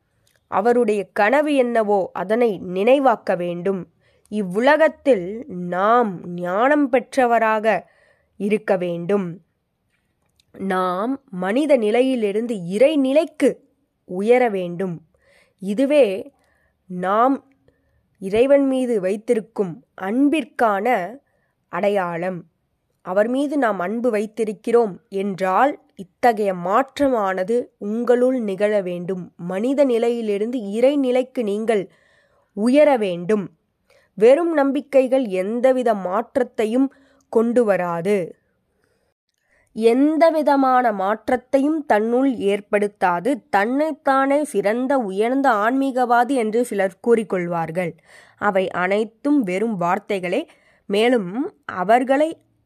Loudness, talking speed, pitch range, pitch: -20 LUFS, 75 wpm, 195-260 Hz, 225 Hz